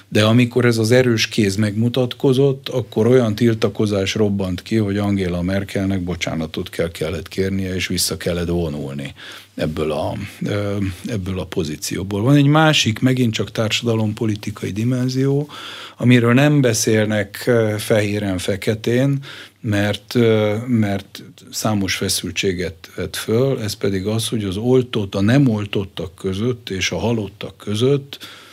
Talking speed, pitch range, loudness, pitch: 125 wpm, 95-120 Hz, -19 LUFS, 110 Hz